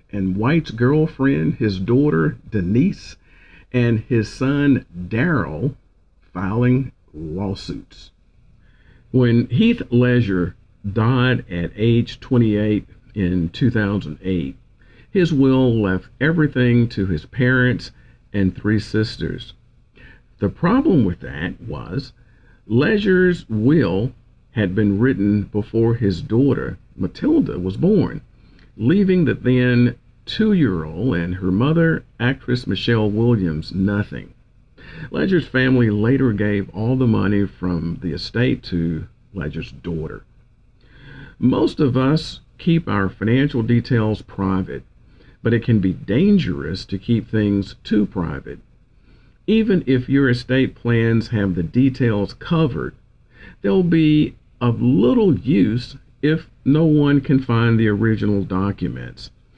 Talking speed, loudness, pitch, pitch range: 115 wpm, -19 LUFS, 115 Hz, 100-130 Hz